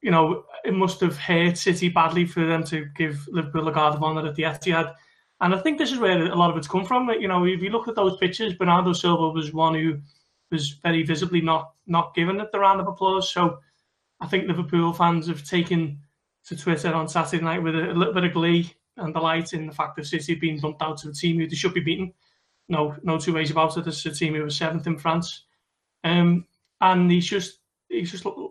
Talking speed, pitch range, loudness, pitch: 235 wpm, 160-180 Hz, -23 LUFS, 170 Hz